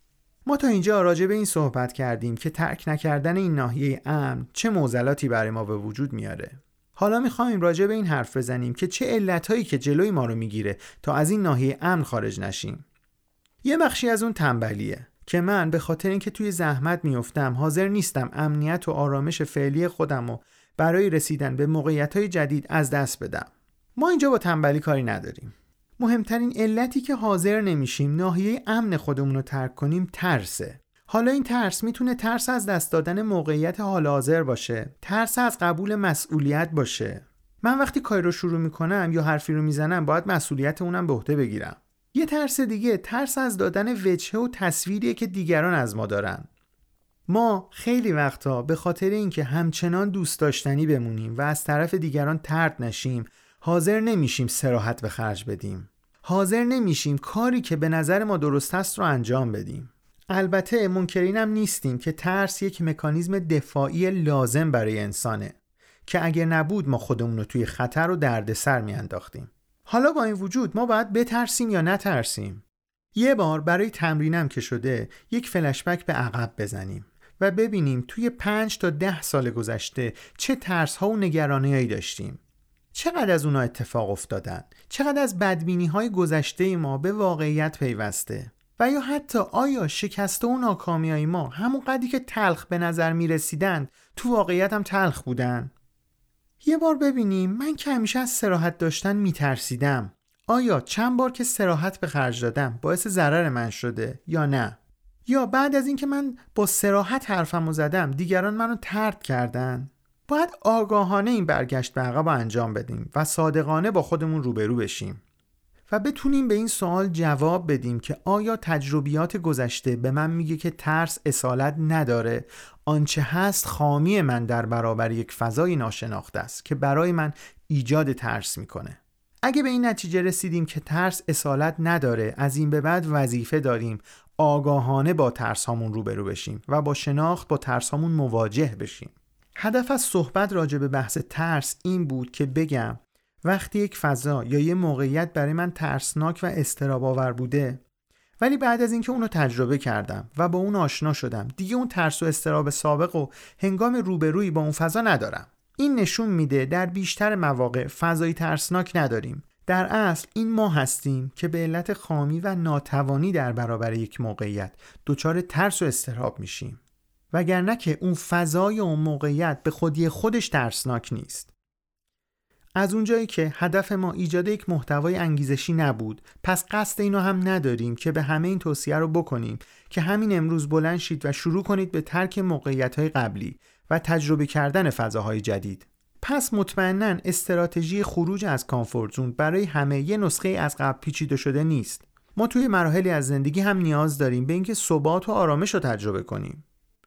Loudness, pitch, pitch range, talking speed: -24 LUFS, 160 Hz, 135-195 Hz, 165 wpm